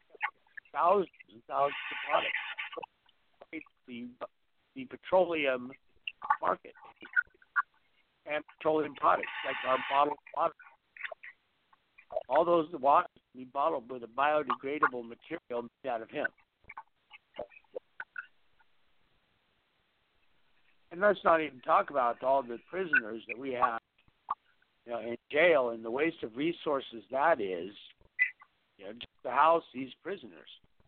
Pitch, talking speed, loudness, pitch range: 140 Hz, 115 wpm, -31 LUFS, 120-170 Hz